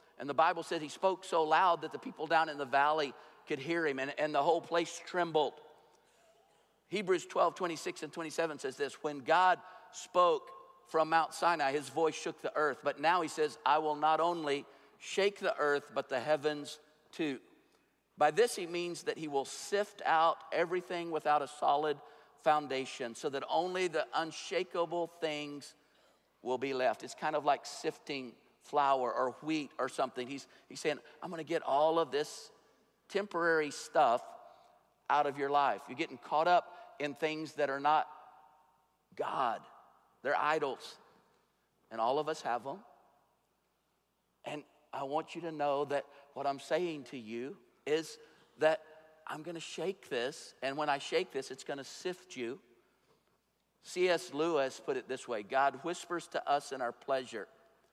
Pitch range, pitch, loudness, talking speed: 145-170 Hz, 155 Hz, -34 LUFS, 170 wpm